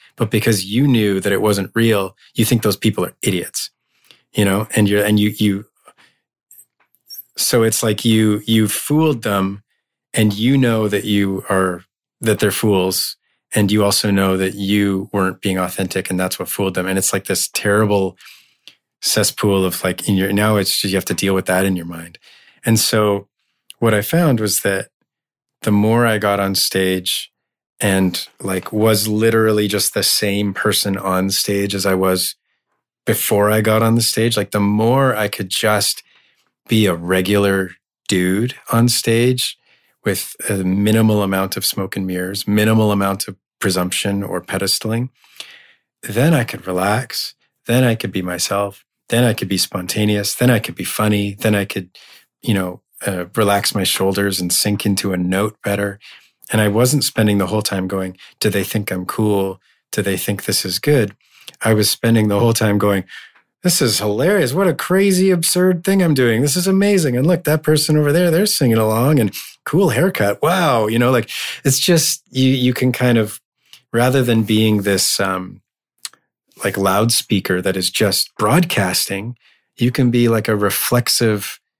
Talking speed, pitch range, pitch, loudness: 180 wpm, 95-115 Hz, 105 Hz, -17 LUFS